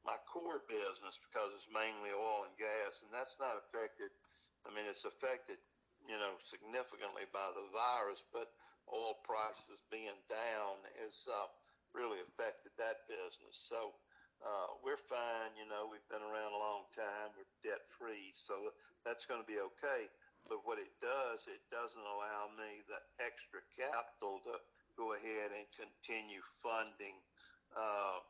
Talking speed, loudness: 155 wpm, -46 LUFS